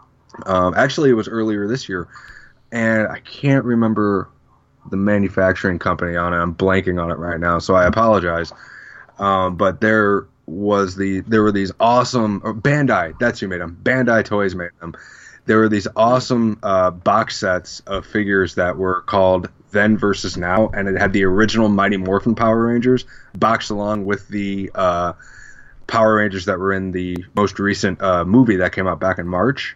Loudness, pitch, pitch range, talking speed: -18 LUFS, 100 Hz, 95-110 Hz, 180 wpm